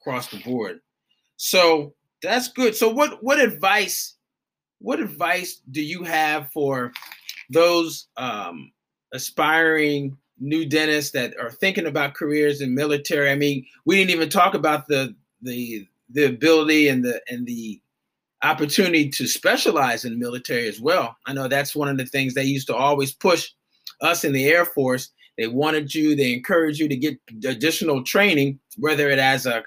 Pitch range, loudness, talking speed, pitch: 135-160 Hz, -21 LUFS, 165 wpm, 145 Hz